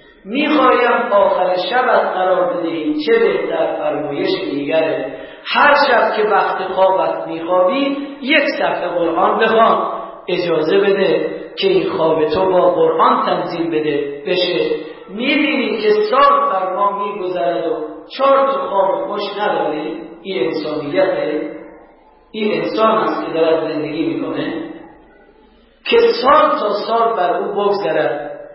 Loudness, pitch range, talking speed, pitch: -16 LUFS, 175-255 Hz, 120 wpm, 195 Hz